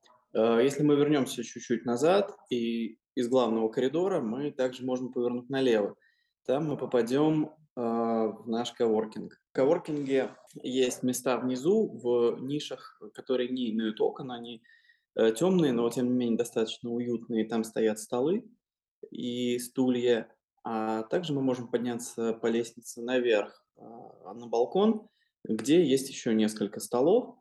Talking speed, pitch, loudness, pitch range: 135 wpm, 125 Hz, -29 LUFS, 115-140 Hz